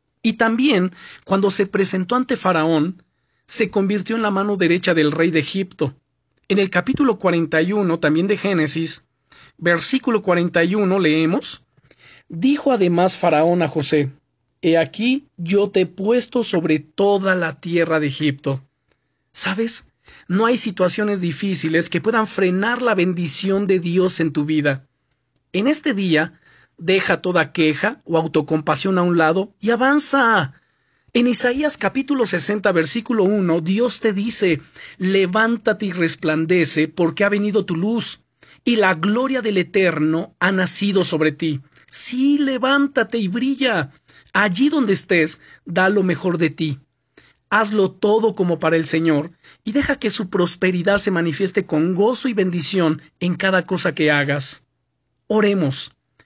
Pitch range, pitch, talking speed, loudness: 160-215 Hz, 185 Hz, 140 wpm, -18 LUFS